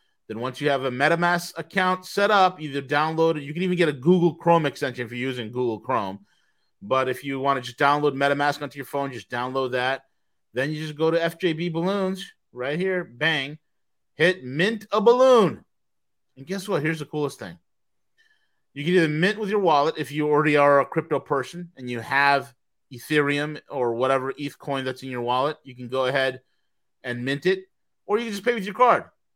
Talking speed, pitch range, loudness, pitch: 205 wpm, 130-175 Hz, -23 LUFS, 145 Hz